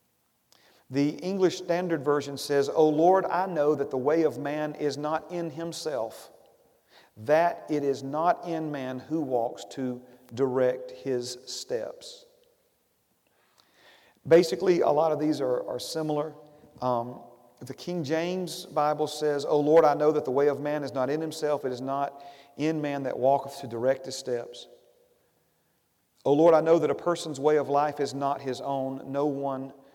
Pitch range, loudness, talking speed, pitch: 135-160 Hz, -27 LUFS, 170 wpm, 145 Hz